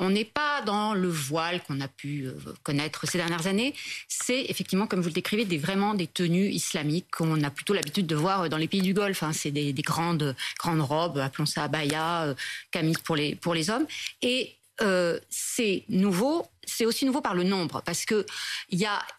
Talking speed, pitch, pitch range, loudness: 205 wpm, 175 Hz, 155-200 Hz, -28 LUFS